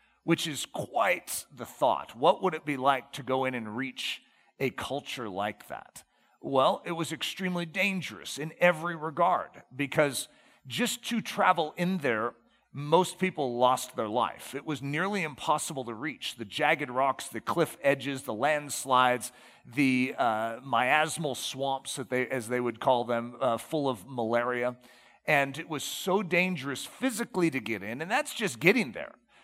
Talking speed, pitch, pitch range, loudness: 165 wpm, 140 Hz, 125-170 Hz, -29 LUFS